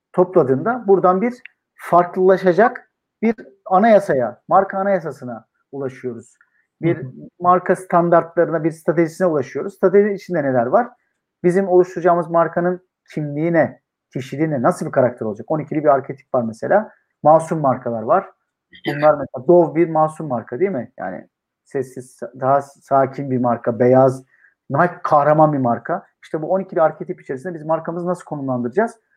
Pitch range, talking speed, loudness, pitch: 135-180 Hz, 130 wpm, -18 LUFS, 165 Hz